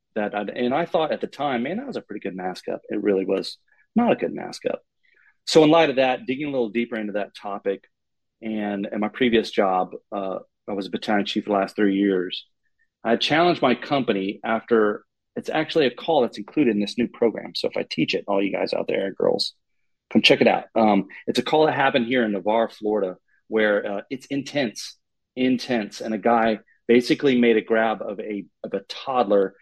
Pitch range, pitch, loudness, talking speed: 105-130 Hz, 110 Hz, -23 LUFS, 220 wpm